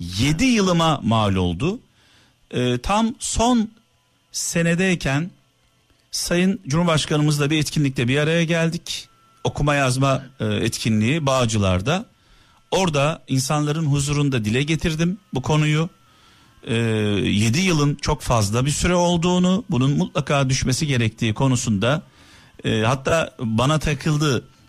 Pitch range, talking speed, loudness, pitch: 125-165 Hz, 105 wpm, -20 LUFS, 145 Hz